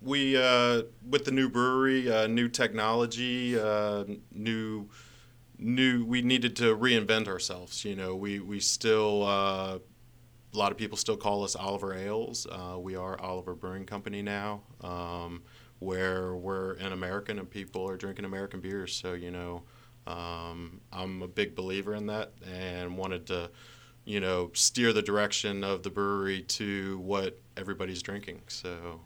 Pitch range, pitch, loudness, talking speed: 95-115 Hz, 100 Hz, -31 LUFS, 155 wpm